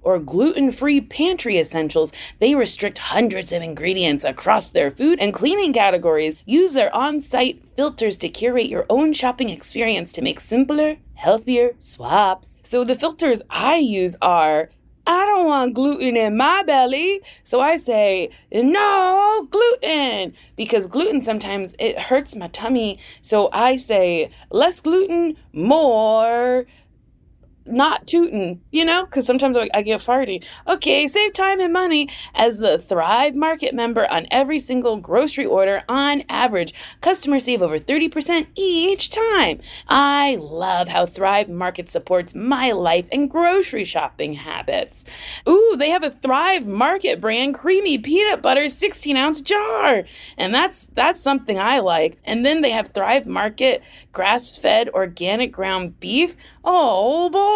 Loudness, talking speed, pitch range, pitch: -18 LUFS, 145 wpm, 210-320 Hz, 260 Hz